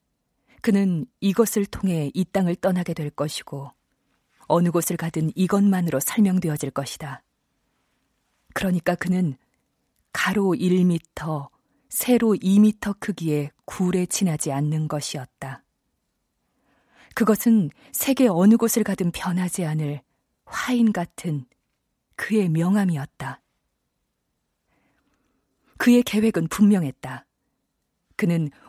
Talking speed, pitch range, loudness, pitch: 215 characters per minute, 155-205 Hz, -22 LUFS, 180 Hz